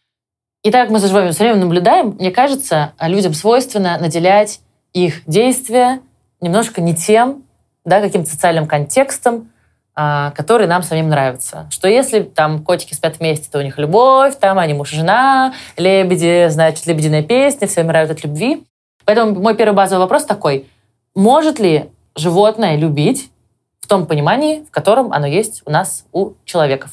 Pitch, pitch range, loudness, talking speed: 180 Hz, 155-220 Hz, -14 LUFS, 160 wpm